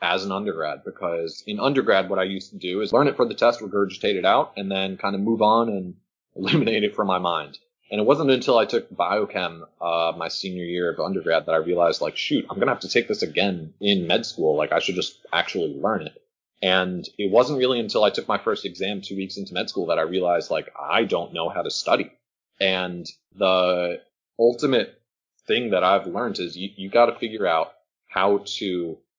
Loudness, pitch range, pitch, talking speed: -23 LUFS, 90-105 Hz, 95 Hz, 220 wpm